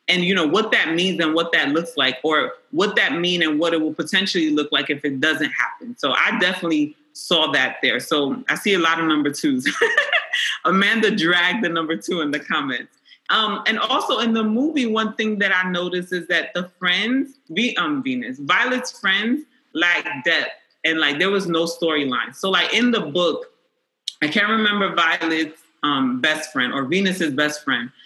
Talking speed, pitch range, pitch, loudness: 200 wpm, 160-225 Hz, 180 Hz, -19 LUFS